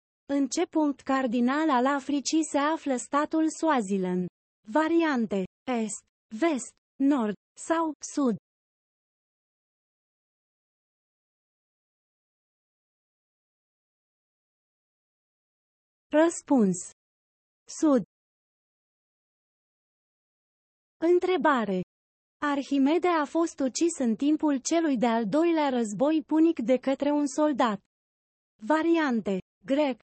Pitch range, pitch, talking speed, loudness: 245-315 Hz, 285 Hz, 70 wpm, -26 LUFS